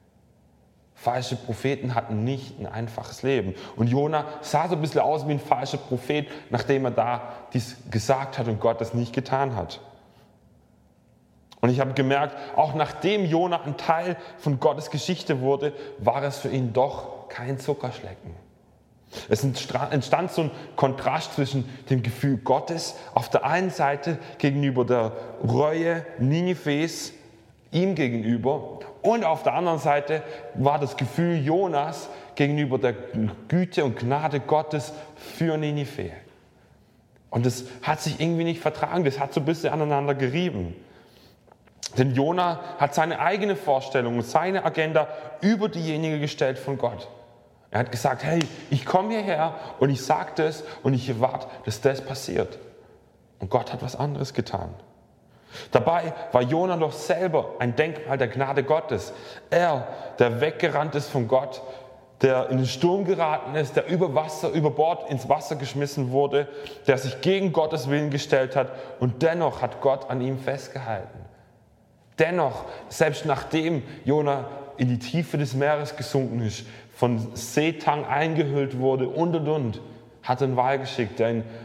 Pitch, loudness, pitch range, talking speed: 140 Hz, -25 LUFS, 125-155 Hz, 150 wpm